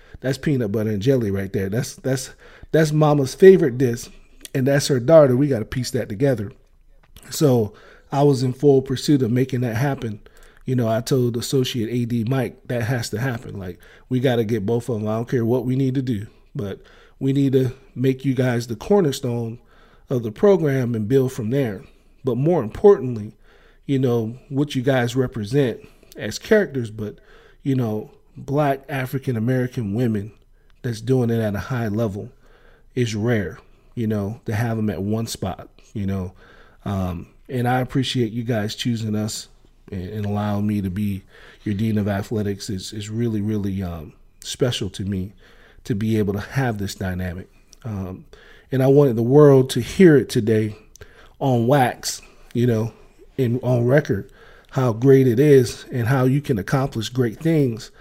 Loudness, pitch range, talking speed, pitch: -21 LUFS, 110-135 Hz, 180 wpm, 120 Hz